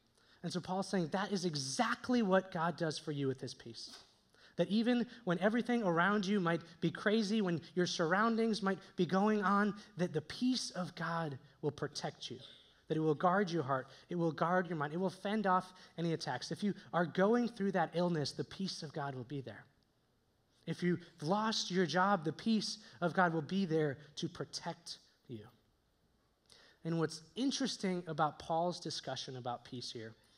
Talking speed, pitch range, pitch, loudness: 185 wpm, 150-195 Hz, 170 Hz, -36 LUFS